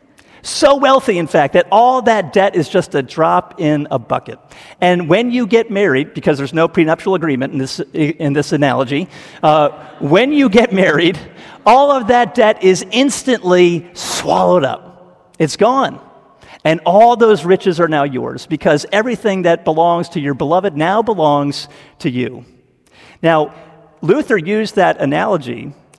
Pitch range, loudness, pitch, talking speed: 150-215 Hz, -14 LUFS, 175 Hz, 155 wpm